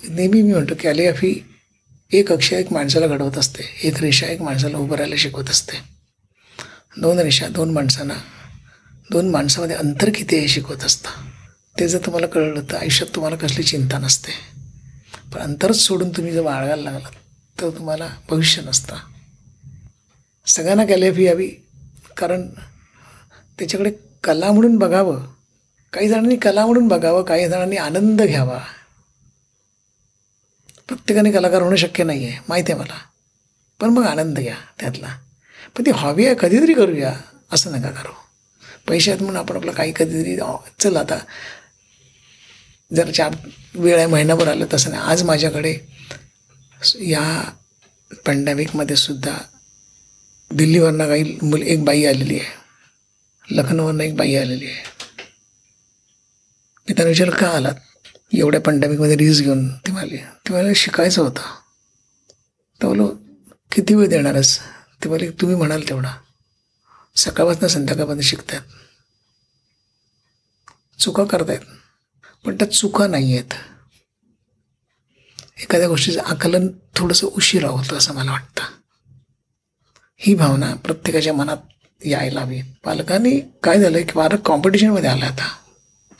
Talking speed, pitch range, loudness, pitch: 125 wpm, 130-175 Hz, -17 LUFS, 155 Hz